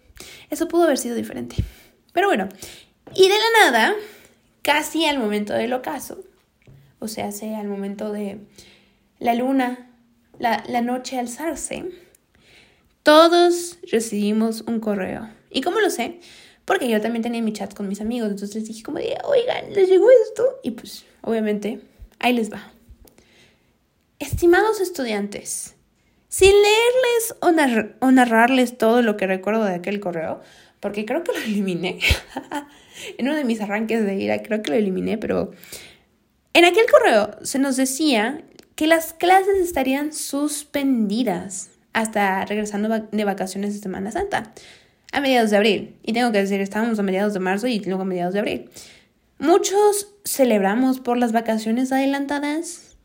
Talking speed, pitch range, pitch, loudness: 150 wpm, 210-320 Hz, 240 Hz, -20 LUFS